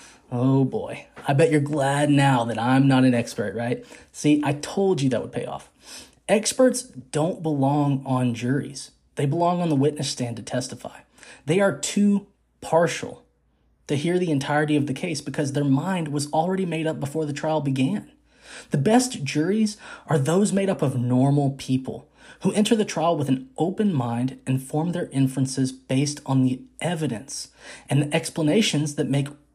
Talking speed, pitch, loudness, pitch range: 175 wpm, 145 Hz, -23 LUFS, 135-165 Hz